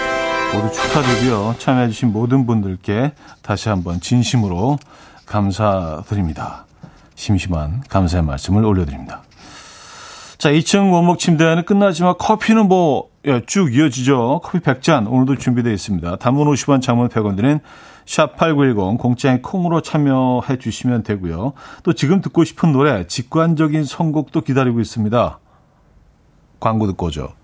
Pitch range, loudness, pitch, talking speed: 105-155 Hz, -17 LUFS, 125 Hz, 295 characters per minute